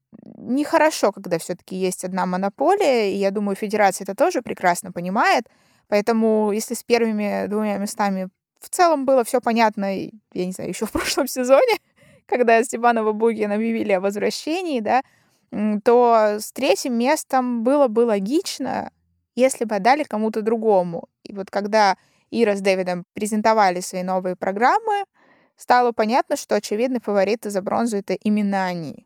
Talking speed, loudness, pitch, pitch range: 145 wpm, -20 LUFS, 215 Hz, 195-250 Hz